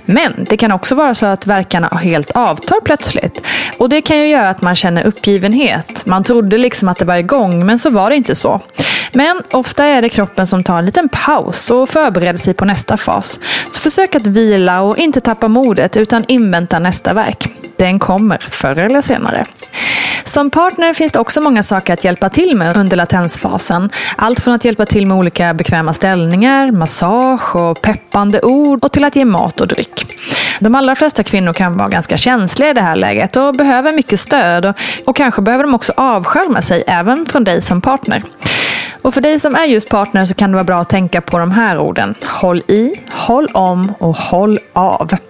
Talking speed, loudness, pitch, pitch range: 200 wpm, -11 LUFS, 215 Hz, 185-265 Hz